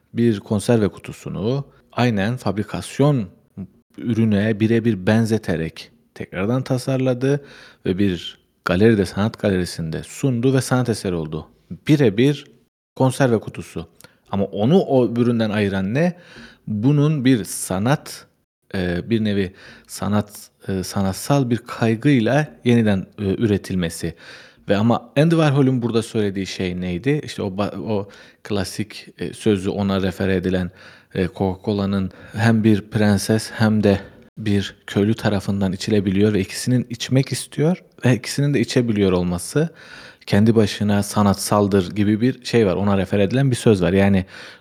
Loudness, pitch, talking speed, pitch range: -20 LUFS, 110 Hz, 120 wpm, 100-125 Hz